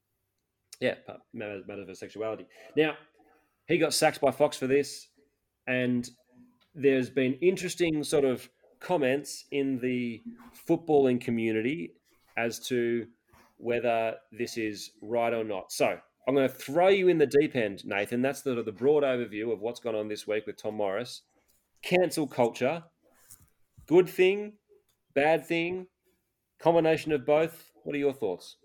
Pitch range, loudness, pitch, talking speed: 120-160 Hz, -28 LUFS, 140 Hz, 145 wpm